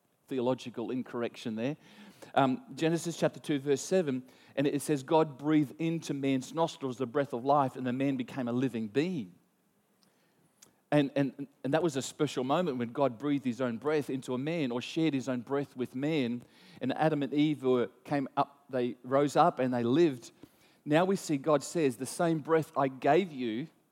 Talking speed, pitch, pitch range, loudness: 190 wpm, 140 Hz, 130-155 Hz, -31 LUFS